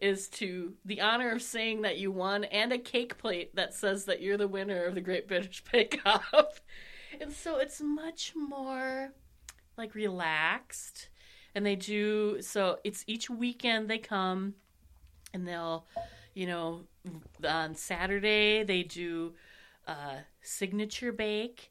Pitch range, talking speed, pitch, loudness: 185-235 Hz, 145 wpm, 205 Hz, -32 LUFS